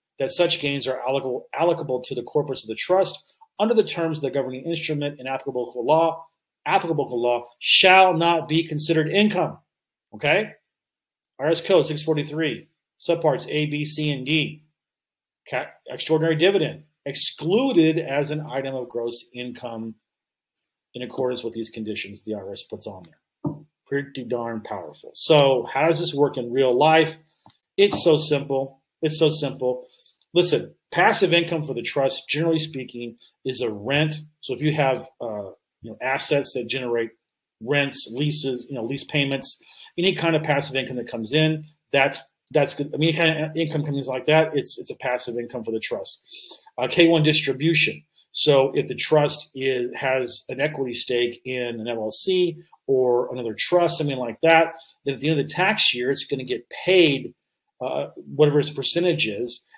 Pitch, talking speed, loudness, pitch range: 145 Hz, 175 wpm, -22 LUFS, 130-160 Hz